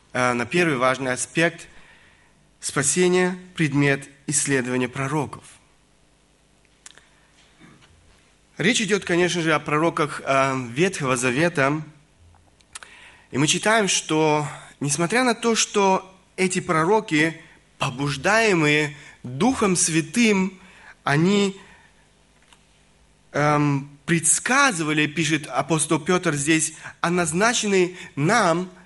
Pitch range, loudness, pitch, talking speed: 140-185 Hz, -21 LUFS, 160 Hz, 80 wpm